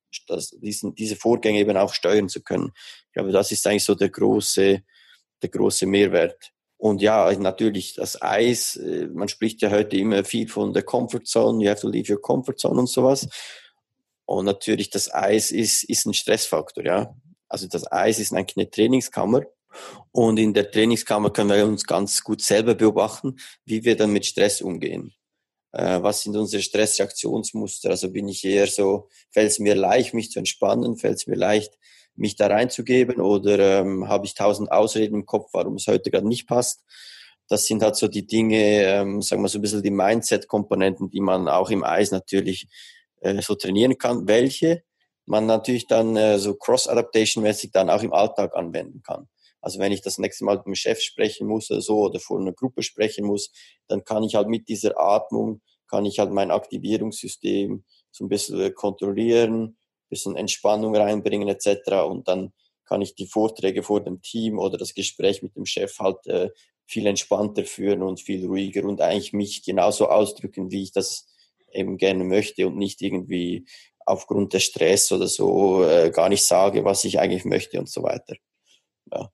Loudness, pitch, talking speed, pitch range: -22 LUFS, 105 Hz, 185 wpm, 100-110 Hz